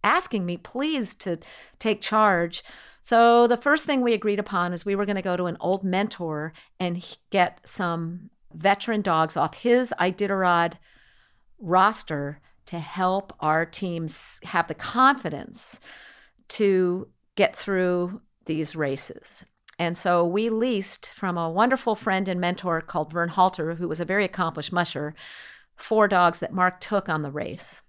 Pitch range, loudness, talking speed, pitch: 170-210 Hz, -24 LUFS, 155 wpm, 180 Hz